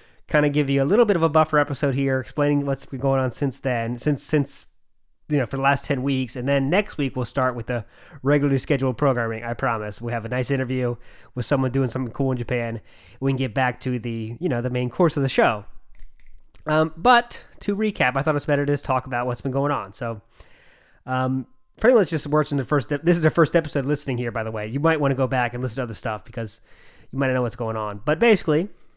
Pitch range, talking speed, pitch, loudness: 120-145 Hz, 255 wpm, 130 Hz, -23 LUFS